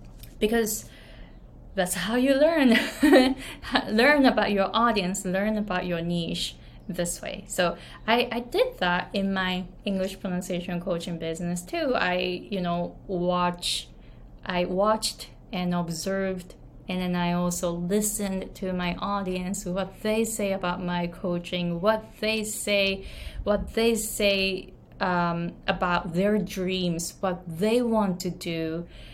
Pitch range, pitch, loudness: 175-215 Hz, 185 Hz, -26 LUFS